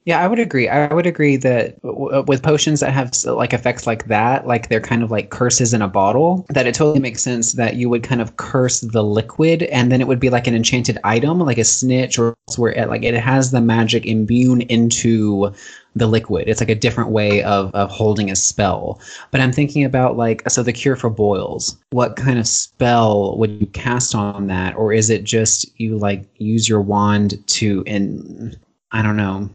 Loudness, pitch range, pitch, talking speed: -16 LUFS, 110-130 Hz, 115 Hz, 215 wpm